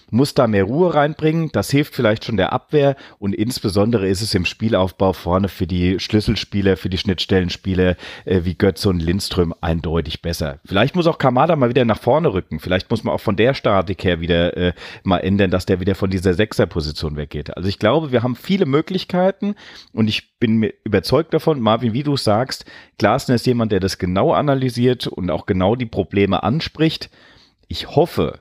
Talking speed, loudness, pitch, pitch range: 190 wpm, -18 LUFS, 100 Hz, 95-125 Hz